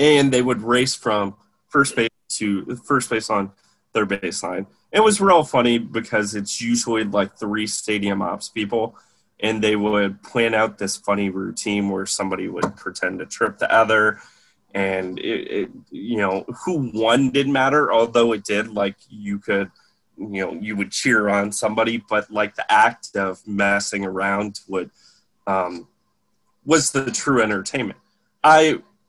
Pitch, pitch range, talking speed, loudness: 110 Hz, 100-125 Hz, 160 wpm, -20 LUFS